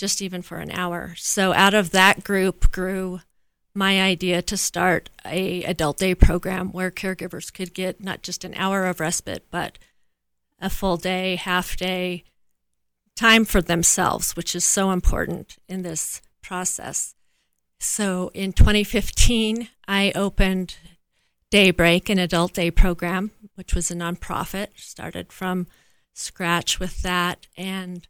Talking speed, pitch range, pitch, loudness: 140 wpm, 175-195 Hz, 185 Hz, -22 LUFS